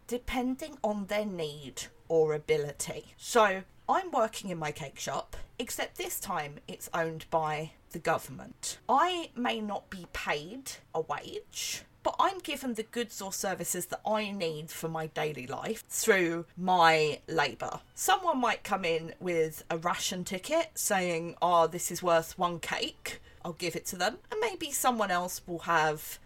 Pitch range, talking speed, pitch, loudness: 160-215 Hz, 160 wpm, 175 Hz, -31 LUFS